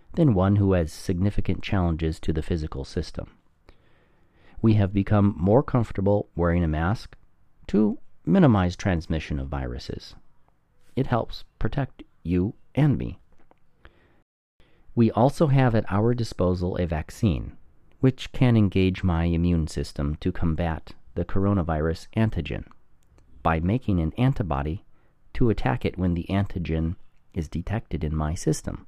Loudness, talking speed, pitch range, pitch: -25 LUFS, 130 wpm, 80-105 Hz, 90 Hz